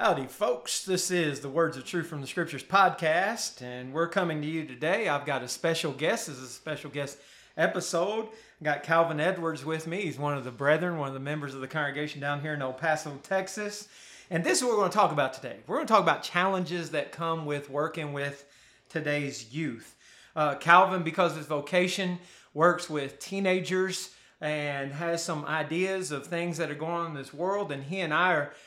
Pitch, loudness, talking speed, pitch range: 160 Hz, -29 LUFS, 215 wpm, 145-180 Hz